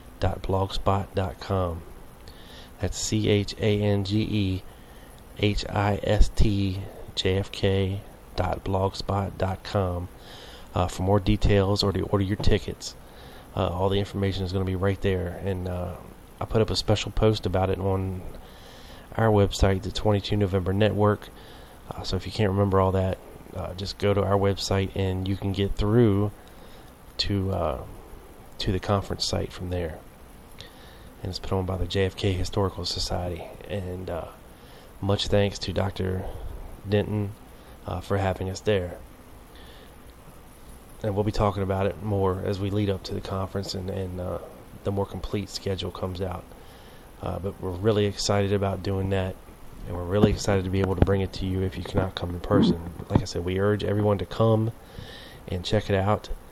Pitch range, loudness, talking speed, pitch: 90-100 Hz, -26 LUFS, 175 wpm, 95 Hz